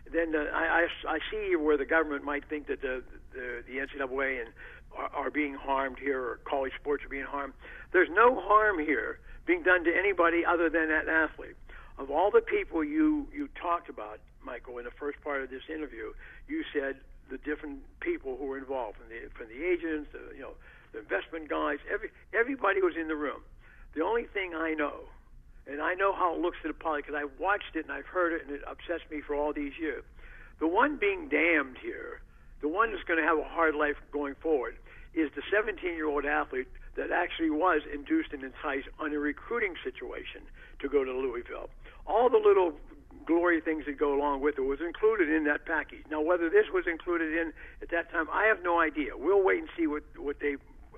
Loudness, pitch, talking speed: -30 LUFS, 165 Hz, 215 wpm